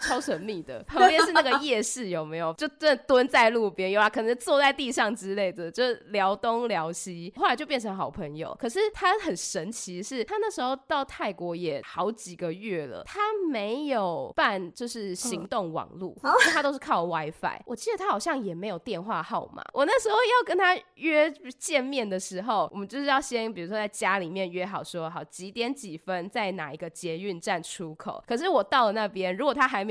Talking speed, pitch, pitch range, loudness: 305 characters per minute, 225 Hz, 185-280 Hz, -27 LUFS